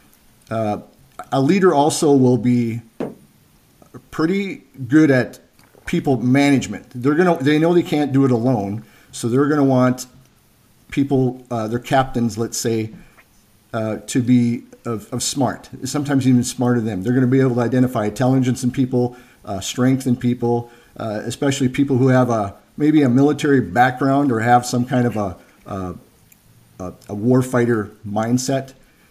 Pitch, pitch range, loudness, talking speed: 125 Hz, 115-135 Hz, -18 LUFS, 160 wpm